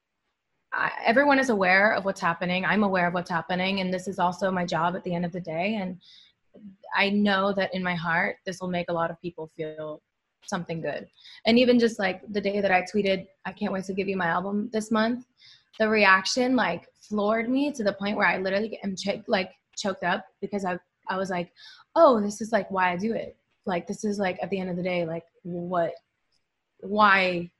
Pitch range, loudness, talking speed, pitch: 180-210 Hz, -25 LUFS, 220 wpm, 190 Hz